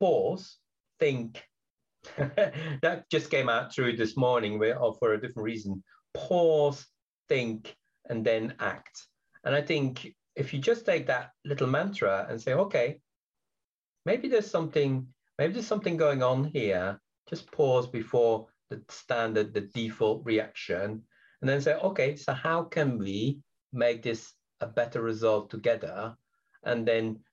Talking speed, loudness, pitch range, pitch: 145 wpm, -29 LUFS, 110-150 Hz, 125 Hz